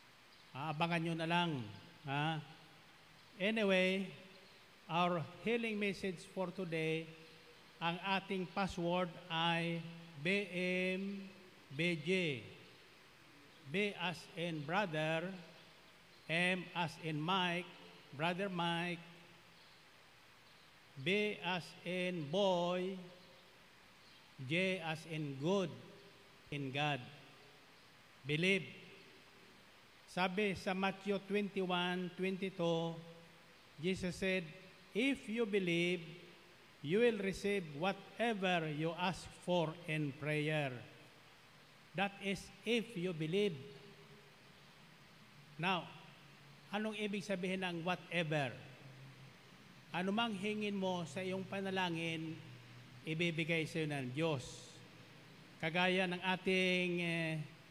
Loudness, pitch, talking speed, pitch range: -38 LUFS, 175 Hz, 85 wpm, 160-190 Hz